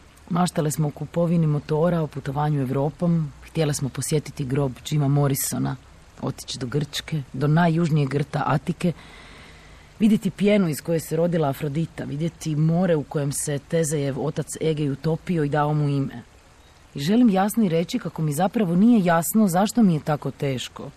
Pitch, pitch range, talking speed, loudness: 155 Hz, 140-170 Hz, 160 wpm, -23 LUFS